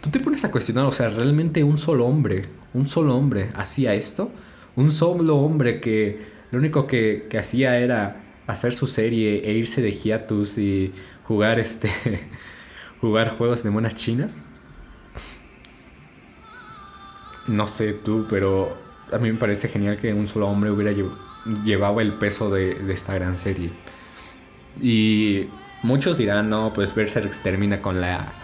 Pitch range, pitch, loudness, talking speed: 100-120 Hz, 110 Hz, -22 LUFS, 155 wpm